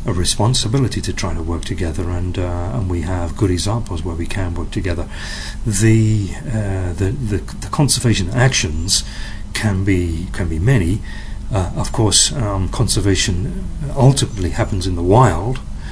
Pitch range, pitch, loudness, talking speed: 90-115 Hz, 100 Hz, -18 LUFS, 155 wpm